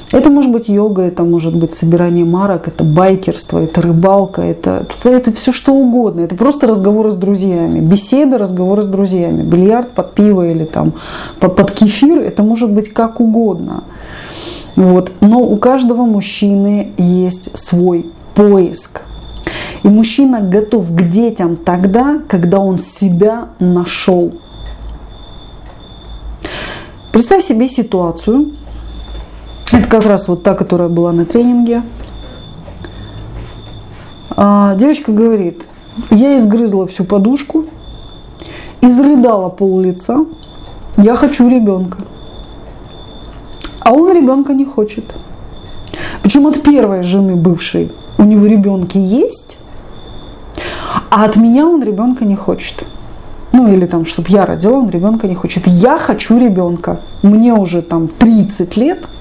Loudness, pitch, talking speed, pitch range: -10 LUFS, 200 Hz, 125 wpm, 175-235 Hz